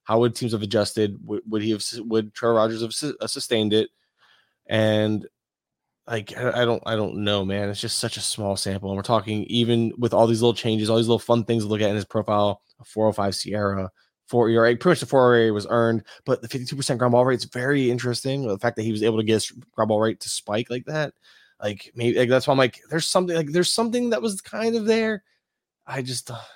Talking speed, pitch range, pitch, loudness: 245 wpm, 110-125 Hz, 115 Hz, -23 LUFS